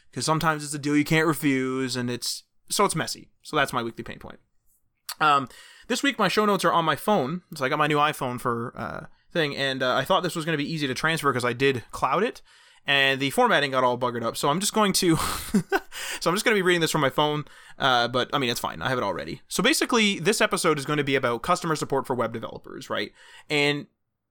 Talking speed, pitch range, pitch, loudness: 255 wpm, 130-175 Hz, 150 Hz, -24 LUFS